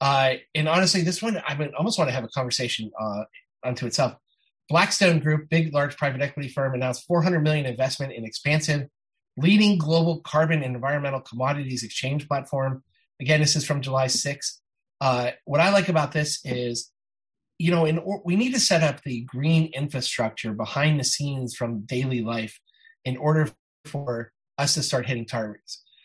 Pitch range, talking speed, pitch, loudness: 125-155 Hz, 170 wpm, 140 Hz, -24 LUFS